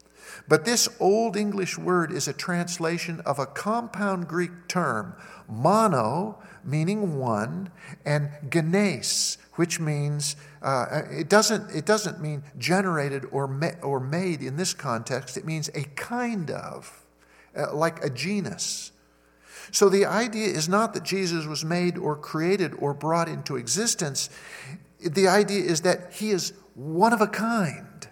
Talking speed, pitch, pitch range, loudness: 145 wpm, 175 Hz, 145-195 Hz, -25 LUFS